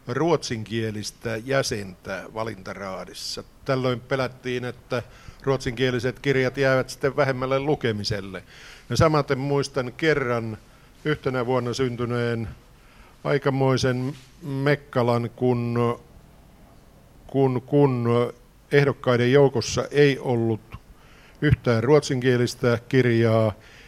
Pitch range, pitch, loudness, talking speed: 120-135 Hz, 125 Hz, -24 LUFS, 80 wpm